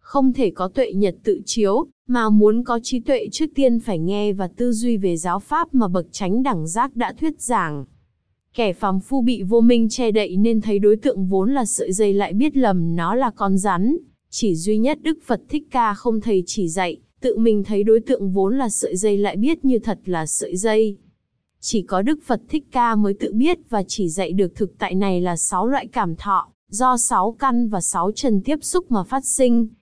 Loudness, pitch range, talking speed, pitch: -20 LUFS, 195-255 Hz, 225 wpm, 220 Hz